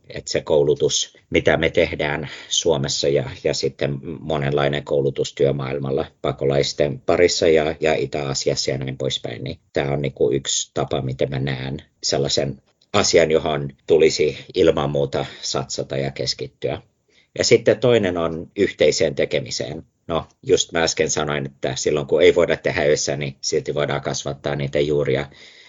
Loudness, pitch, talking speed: -20 LUFS, 70 Hz, 145 wpm